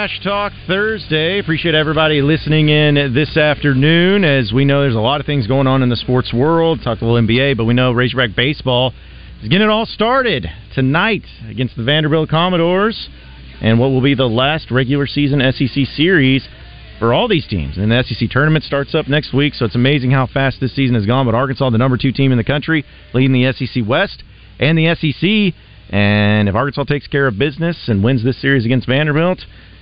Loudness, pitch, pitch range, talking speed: -14 LUFS, 135 Hz, 120-155 Hz, 205 wpm